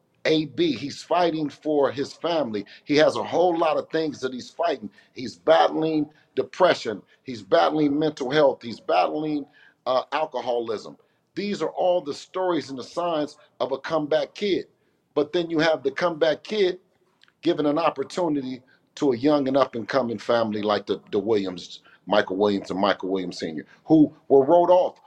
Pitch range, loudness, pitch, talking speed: 135-175 Hz, -24 LUFS, 150 Hz, 170 wpm